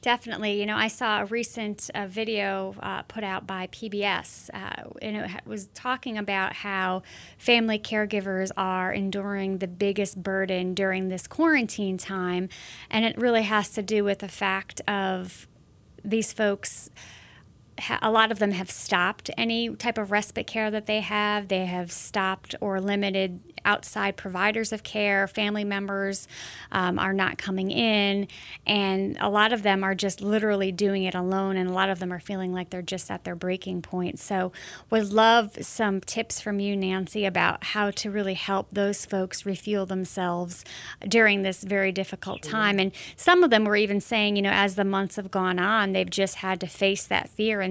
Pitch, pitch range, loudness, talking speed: 200 Hz, 190-210 Hz, -26 LUFS, 180 wpm